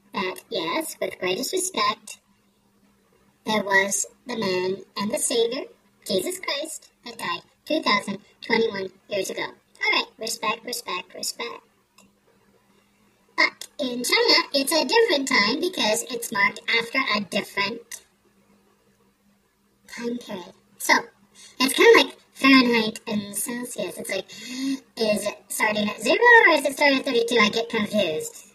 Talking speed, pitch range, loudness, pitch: 130 wpm, 210-300 Hz, -22 LUFS, 235 Hz